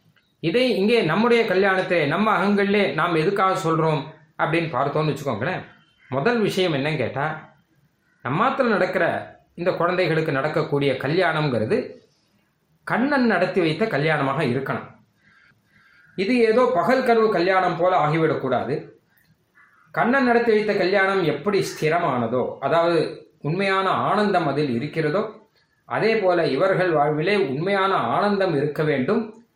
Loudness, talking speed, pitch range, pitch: -21 LUFS, 110 wpm, 155-205 Hz, 185 Hz